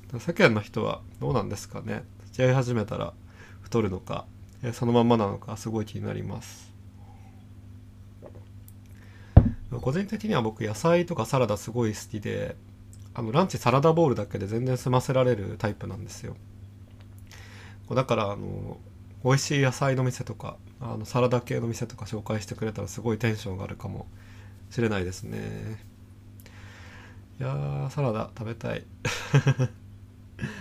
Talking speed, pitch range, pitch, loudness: 300 characters per minute, 100-120 Hz, 110 Hz, -27 LUFS